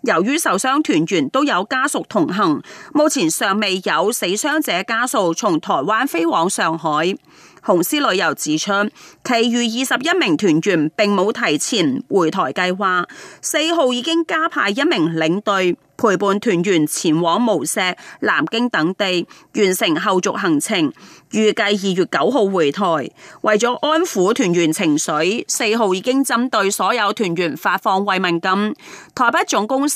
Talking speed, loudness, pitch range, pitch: 230 characters per minute, -17 LUFS, 185-295 Hz, 220 Hz